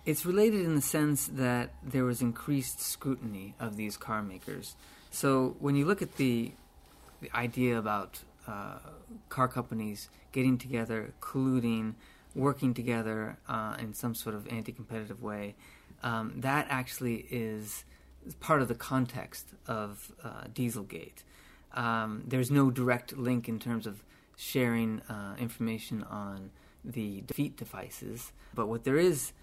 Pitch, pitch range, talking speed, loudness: 115 Hz, 105-130 Hz, 140 wpm, -33 LUFS